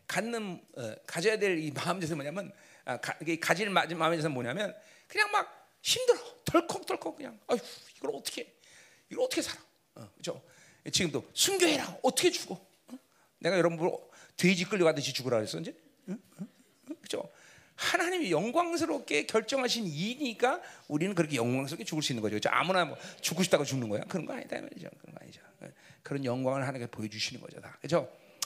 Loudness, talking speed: -31 LUFS, 365 characters per minute